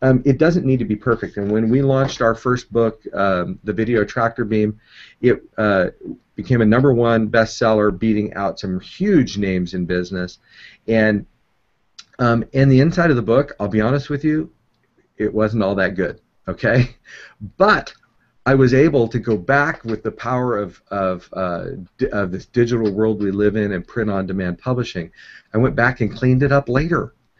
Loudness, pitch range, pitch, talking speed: -18 LUFS, 105-125 Hz, 115 Hz, 185 wpm